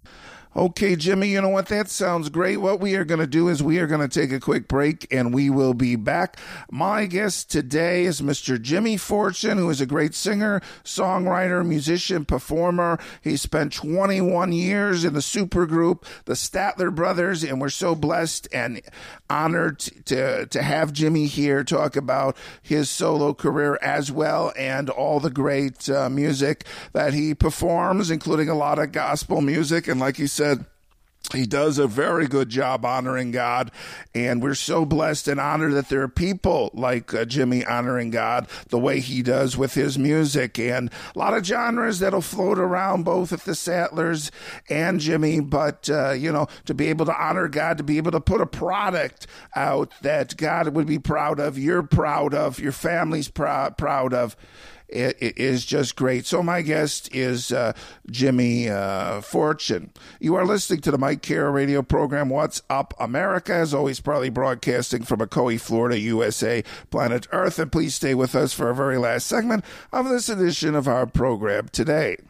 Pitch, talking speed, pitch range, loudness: 150 Hz, 180 wpm, 135-175 Hz, -23 LUFS